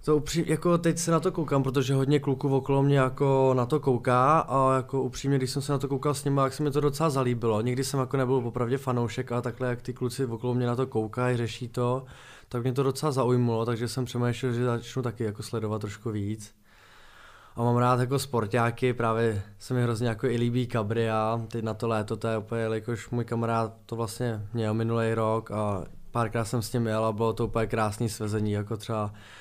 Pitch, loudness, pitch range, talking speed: 120 Hz, -27 LUFS, 115-135 Hz, 220 wpm